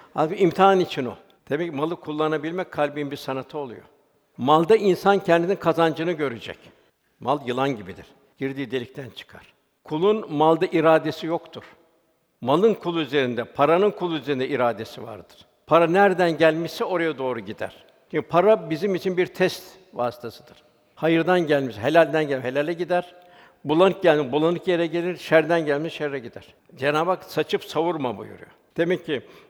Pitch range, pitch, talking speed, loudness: 140-180 Hz, 160 Hz, 140 wpm, -22 LUFS